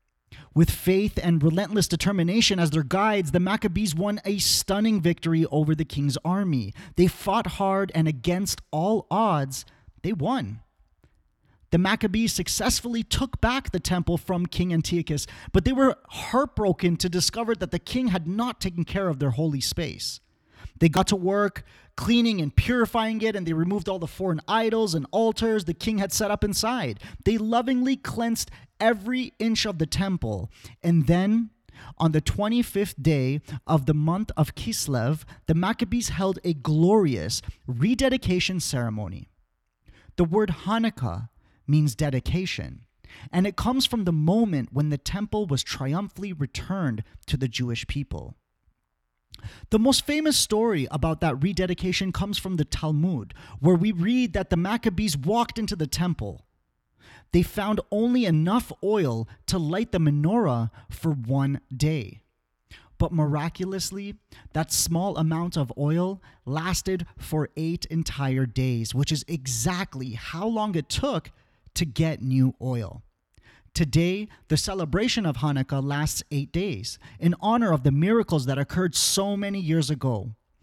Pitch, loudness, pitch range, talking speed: 170 Hz, -25 LUFS, 140-200 Hz, 150 wpm